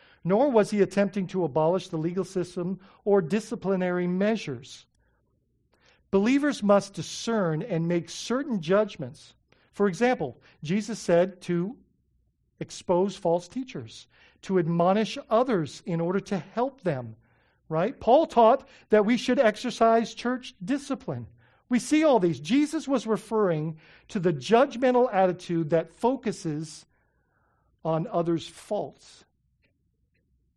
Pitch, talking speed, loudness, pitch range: 190 Hz, 120 wpm, -26 LUFS, 165-225 Hz